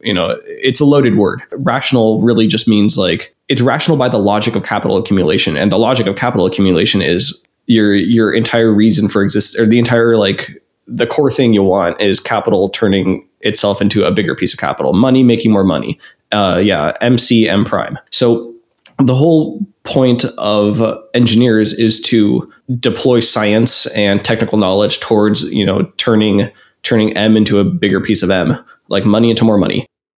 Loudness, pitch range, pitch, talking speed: -12 LUFS, 105-120 Hz, 110 Hz, 180 wpm